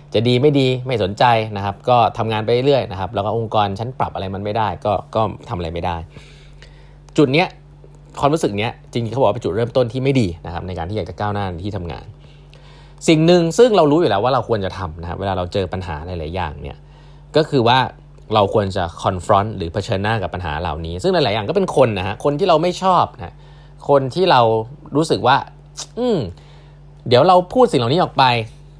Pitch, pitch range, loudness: 115 Hz, 95-145 Hz, -18 LUFS